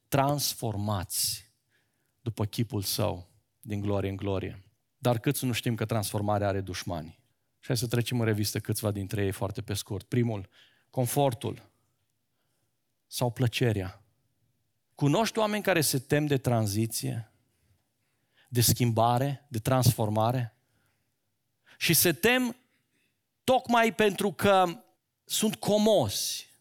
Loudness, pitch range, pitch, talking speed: -28 LUFS, 110-135 Hz, 120 Hz, 115 wpm